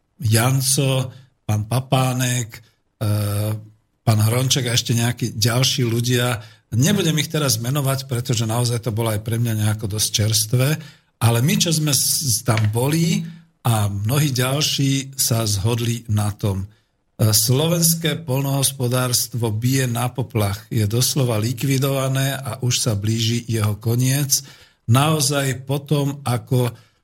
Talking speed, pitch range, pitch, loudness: 120 wpm, 115-135 Hz, 125 Hz, -19 LUFS